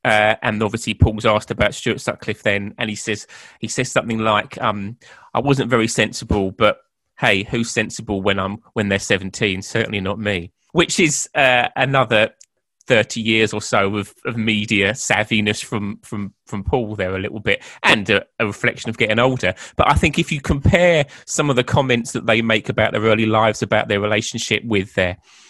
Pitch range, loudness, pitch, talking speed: 105-120 Hz, -18 LUFS, 110 Hz, 195 wpm